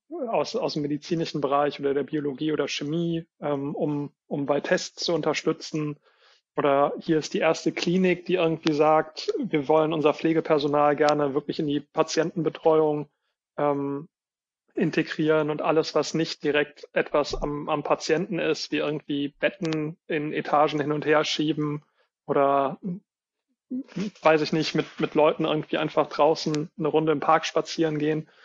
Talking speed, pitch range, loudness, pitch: 150 wpm, 150-160 Hz, -25 LUFS, 155 Hz